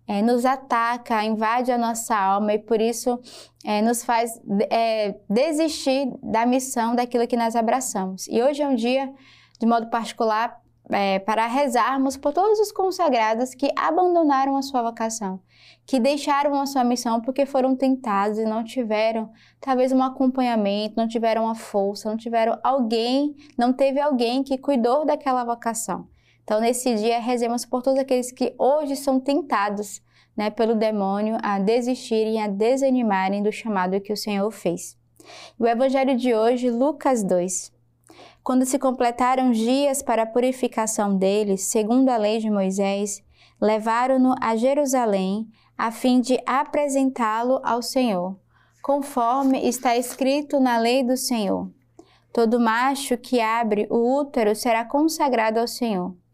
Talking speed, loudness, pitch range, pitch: 145 wpm, -22 LUFS, 220-265 Hz, 235 Hz